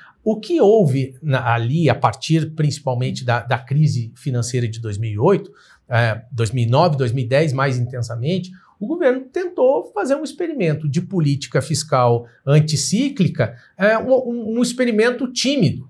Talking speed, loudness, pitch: 125 wpm, -19 LUFS, 150 Hz